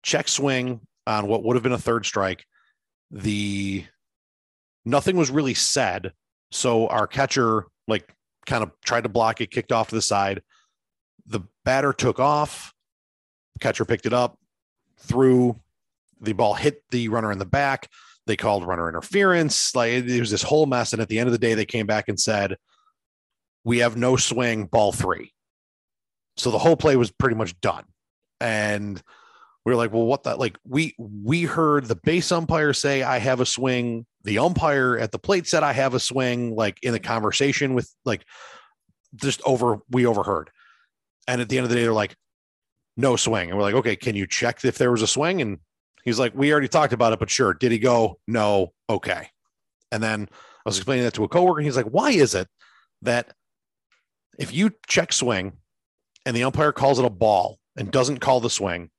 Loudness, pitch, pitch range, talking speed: -22 LUFS, 120 Hz, 110-135 Hz, 195 wpm